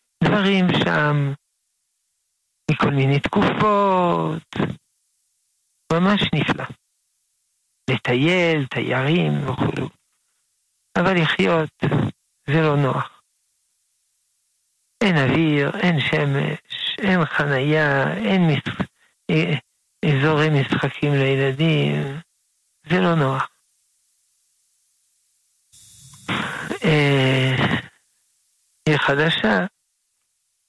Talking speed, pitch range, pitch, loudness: 65 wpm, 135-170 Hz, 150 Hz, -20 LUFS